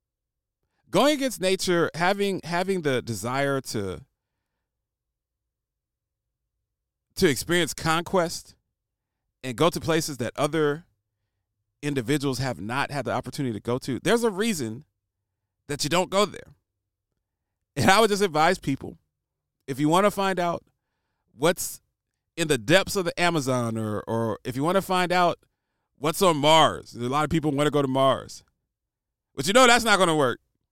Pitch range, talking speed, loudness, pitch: 115-175 Hz, 160 wpm, -24 LUFS, 145 Hz